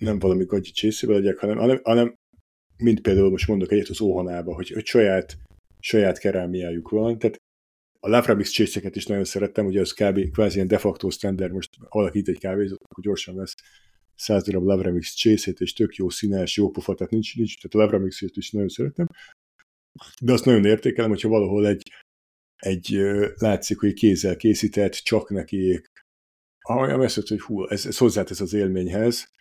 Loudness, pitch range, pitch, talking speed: -23 LUFS, 95-105 Hz, 100 Hz, 175 wpm